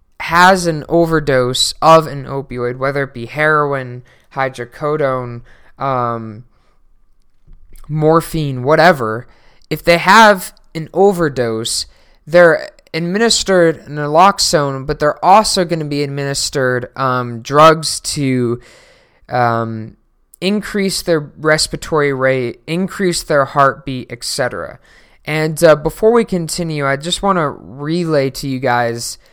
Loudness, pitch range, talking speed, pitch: -14 LUFS, 125-165 Hz, 110 wpm, 145 Hz